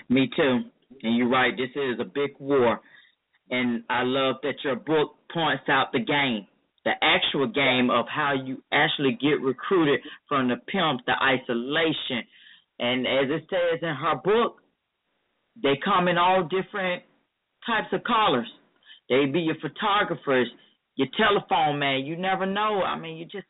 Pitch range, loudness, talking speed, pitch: 130-180 Hz, -24 LUFS, 160 wpm, 140 Hz